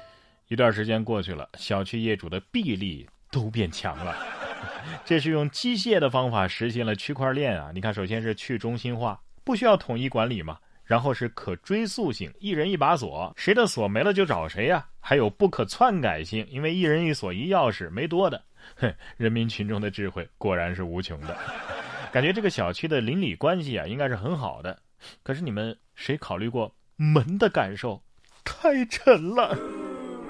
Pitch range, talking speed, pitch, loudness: 100-155 Hz, 275 characters per minute, 115 Hz, -26 LUFS